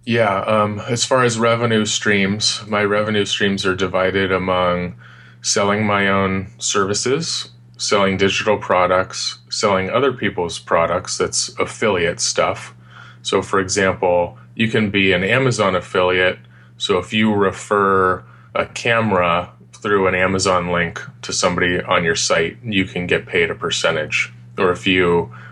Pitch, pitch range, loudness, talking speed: 95 Hz, 90-105 Hz, -18 LUFS, 140 wpm